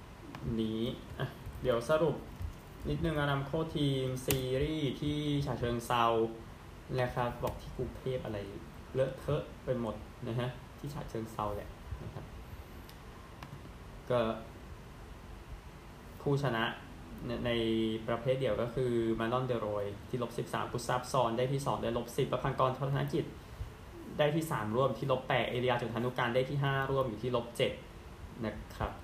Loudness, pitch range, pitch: -35 LUFS, 110-135 Hz, 120 Hz